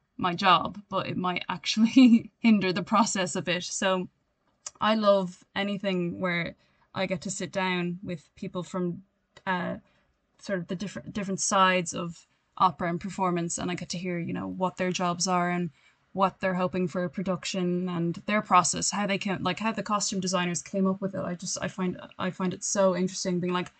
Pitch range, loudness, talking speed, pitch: 180-195 Hz, -27 LUFS, 200 wpm, 185 Hz